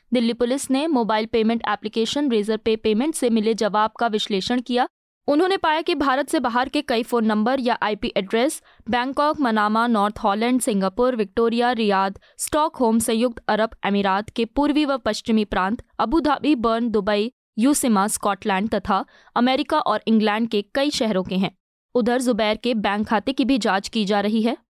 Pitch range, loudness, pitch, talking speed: 215-260 Hz, -21 LUFS, 230 Hz, 170 wpm